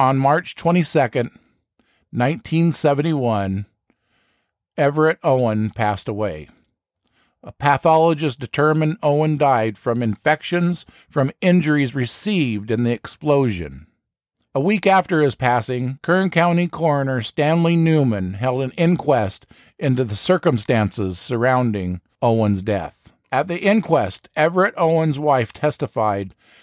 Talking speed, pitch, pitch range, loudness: 105 wpm, 135 Hz, 115-160 Hz, -19 LUFS